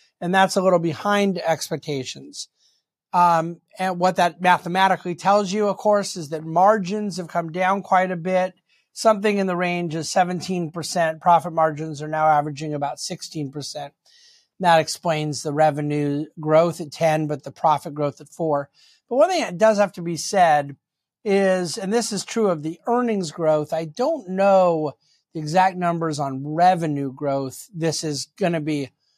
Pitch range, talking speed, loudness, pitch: 155-190 Hz, 170 wpm, -21 LUFS, 170 Hz